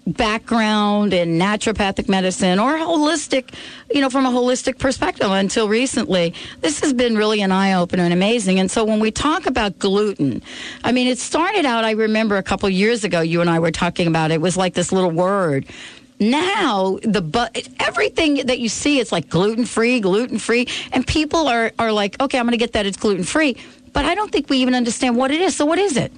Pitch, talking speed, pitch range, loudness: 225 Hz, 210 wpm, 190-260 Hz, -18 LUFS